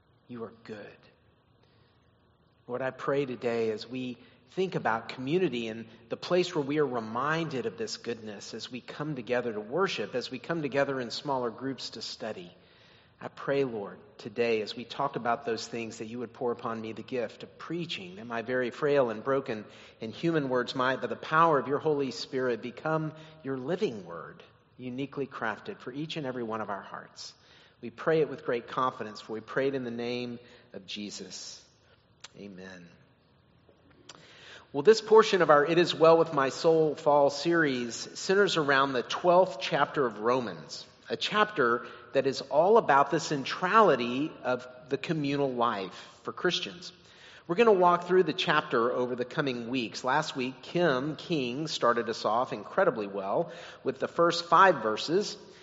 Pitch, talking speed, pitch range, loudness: 135 Hz, 175 wpm, 120-160 Hz, -29 LUFS